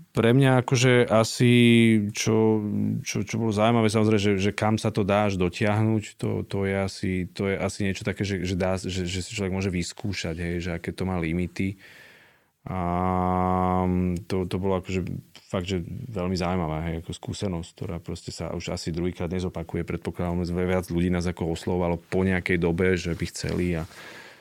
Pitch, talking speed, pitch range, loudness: 95 Hz, 180 wpm, 90-105 Hz, -25 LUFS